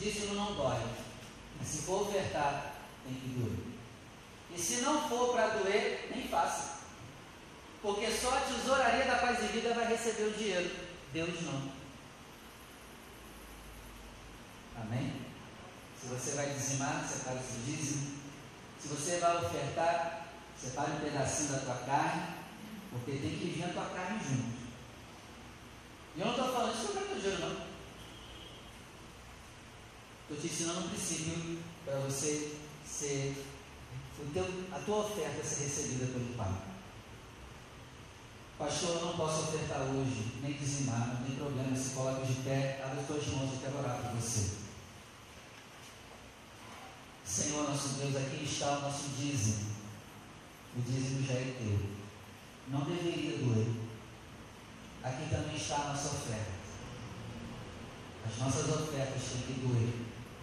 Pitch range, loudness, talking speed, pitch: 120-160 Hz, -36 LUFS, 140 wpm, 135 Hz